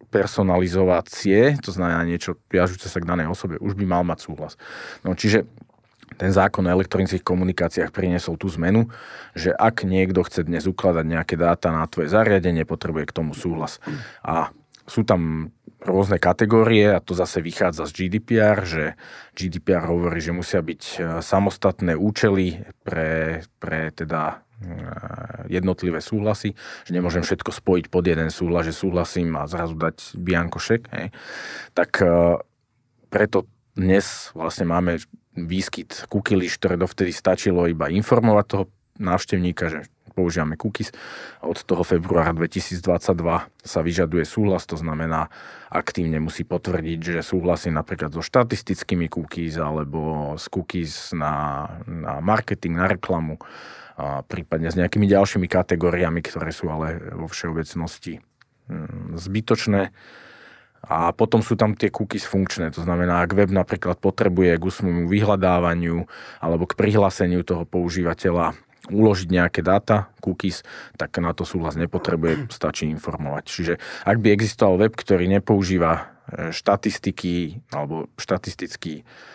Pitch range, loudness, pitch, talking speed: 85-100 Hz, -22 LUFS, 90 Hz, 130 wpm